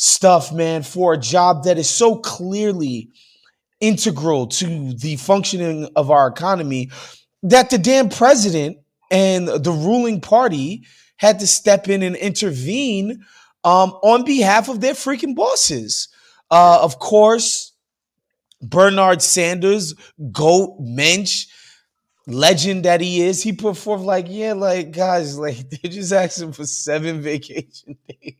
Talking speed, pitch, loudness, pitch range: 135 wpm, 185 Hz, -16 LUFS, 155-205 Hz